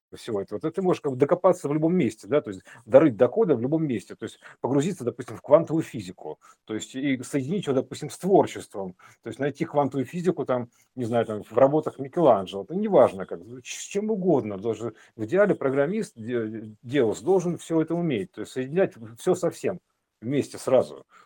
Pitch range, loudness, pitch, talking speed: 115-170 Hz, -25 LUFS, 140 Hz, 200 wpm